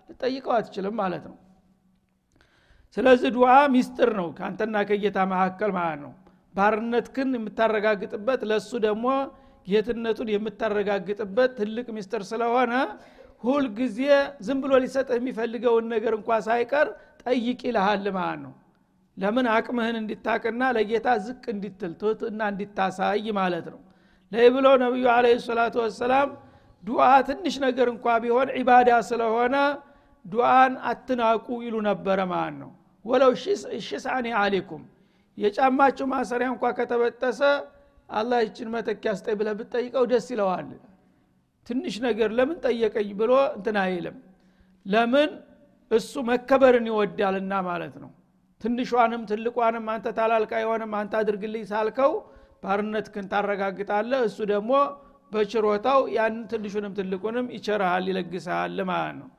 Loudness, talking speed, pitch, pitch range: -24 LUFS, 115 wpm, 225 Hz, 205-250 Hz